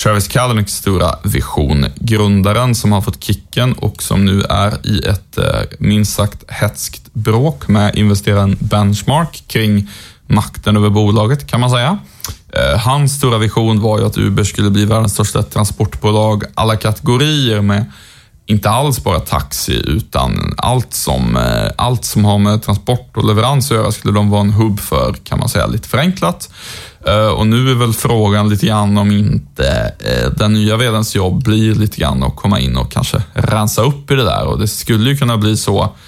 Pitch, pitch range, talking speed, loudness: 105 Hz, 100-115 Hz, 175 wpm, -14 LUFS